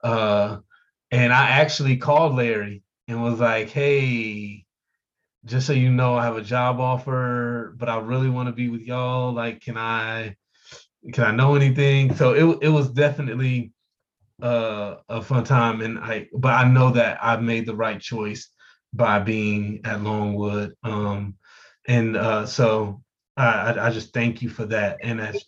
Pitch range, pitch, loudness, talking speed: 110-125 Hz, 120 Hz, -22 LUFS, 165 wpm